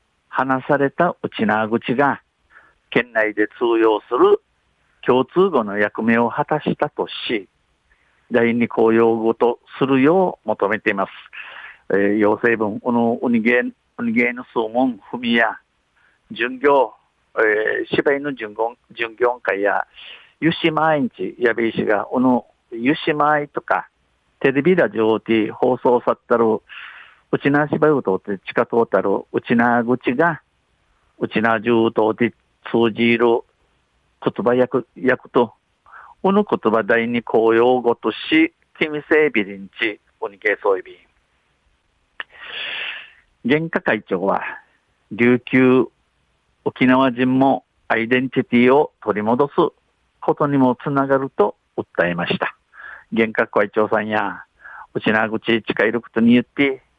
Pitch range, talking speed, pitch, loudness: 110-140 Hz, 235 characters per minute, 120 Hz, -19 LUFS